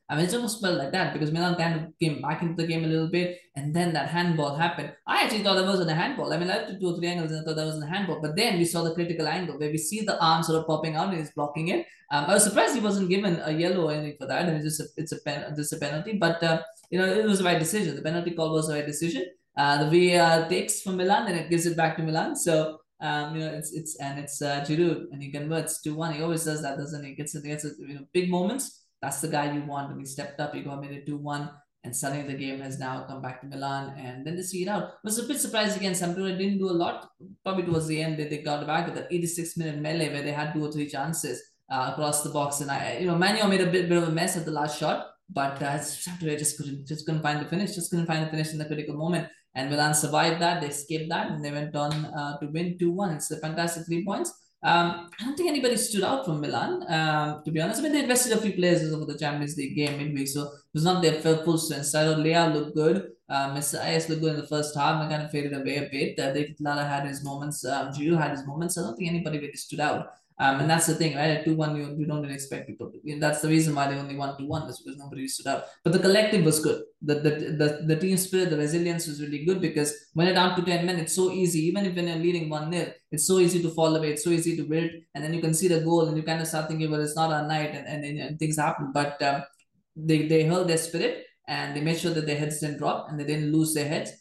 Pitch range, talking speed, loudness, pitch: 150-175 Hz, 290 wpm, -27 LUFS, 160 Hz